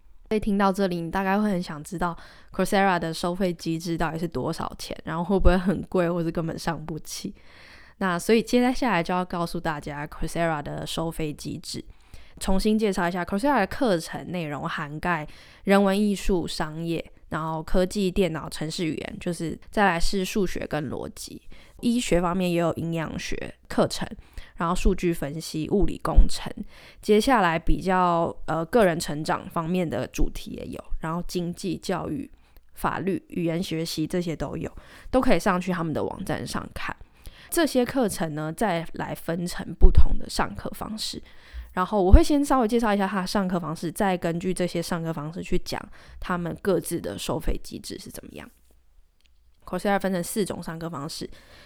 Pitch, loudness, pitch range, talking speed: 175 Hz, -26 LUFS, 165-195 Hz, 295 characters per minute